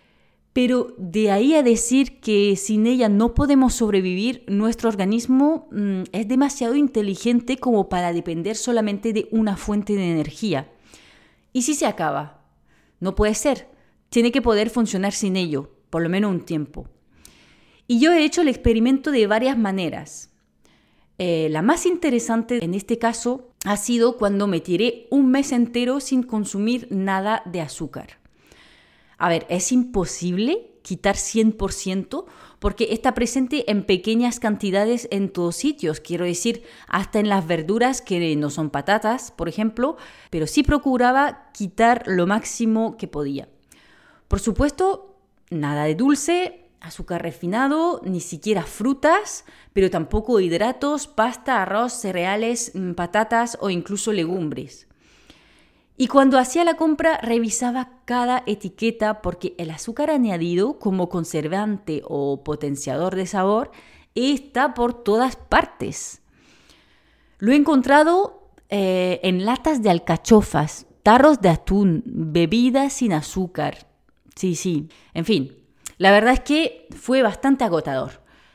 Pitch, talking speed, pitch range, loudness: 220 Hz, 135 wpm, 185-255 Hz, -21 LUFS